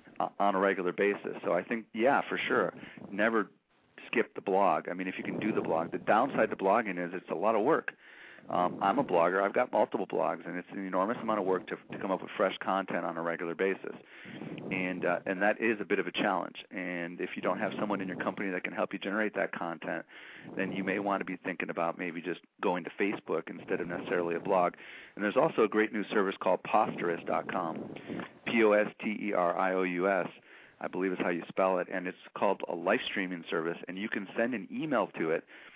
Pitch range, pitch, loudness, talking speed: 90-100 Hz, 95 Hz, -32 LUFS, 225 wpm